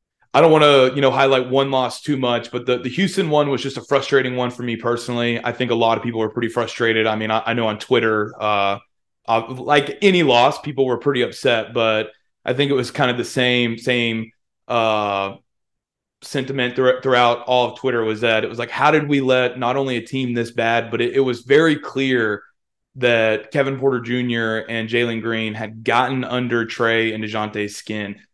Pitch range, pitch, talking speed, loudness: 115-130 Hz, 120 Hz, 210 wpm, -19 LUFS